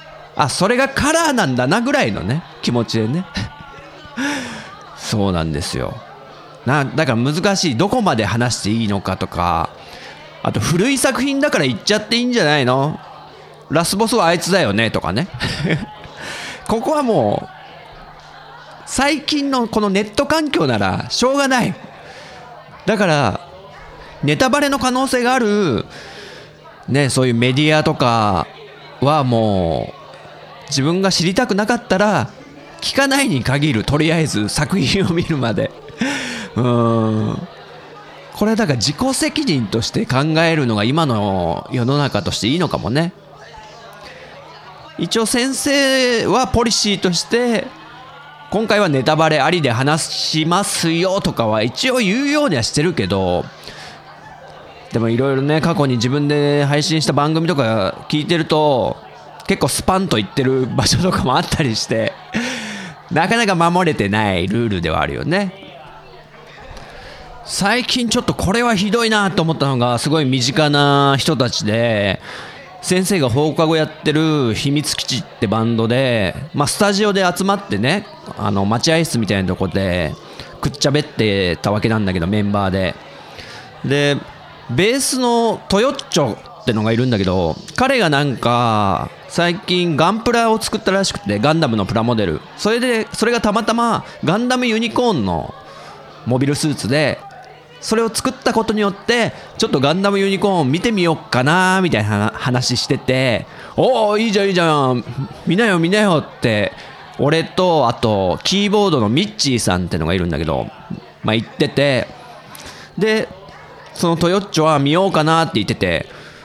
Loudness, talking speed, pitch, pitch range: -17 LUFS, 305 characters per minute, 155 Hz, 120-205 Hz